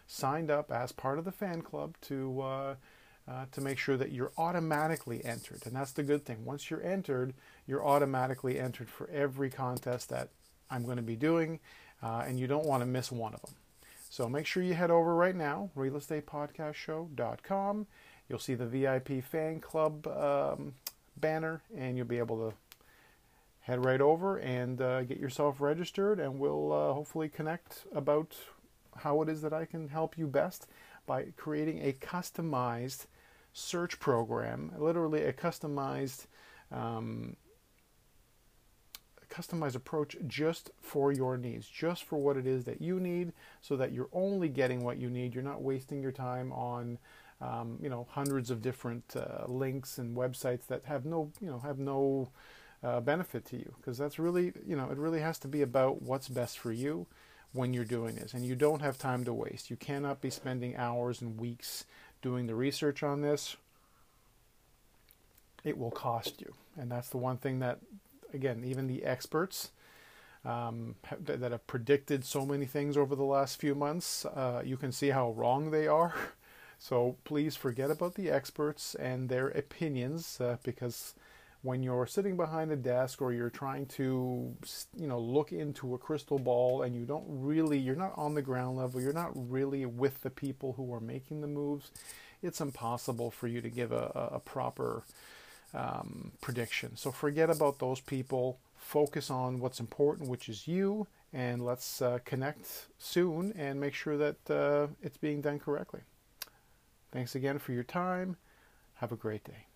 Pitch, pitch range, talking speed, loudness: 135 Hz, 125-150 Hz, 175 wpm, -35 LUFS